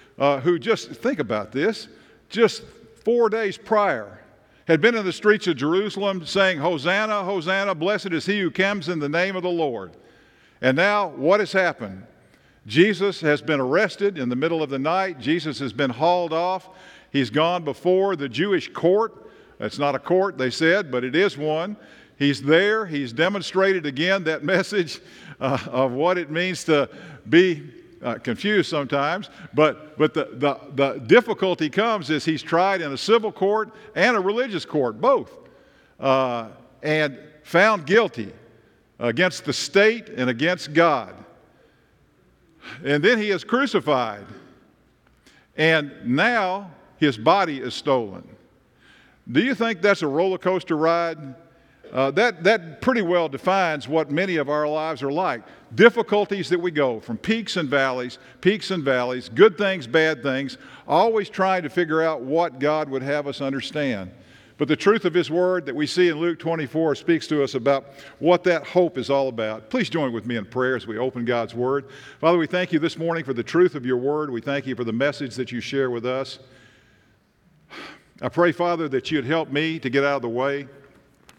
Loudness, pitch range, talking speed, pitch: -22 LUFS, 140-190 Hz, 175 wpm, 160 Hz